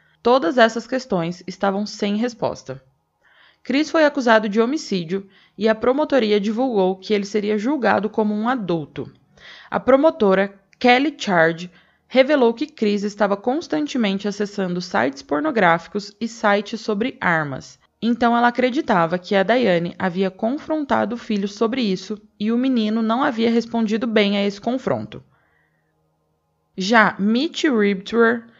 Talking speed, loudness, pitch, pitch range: 130 wpm, -20 LUFS, 215 Hz, 195-240 Hz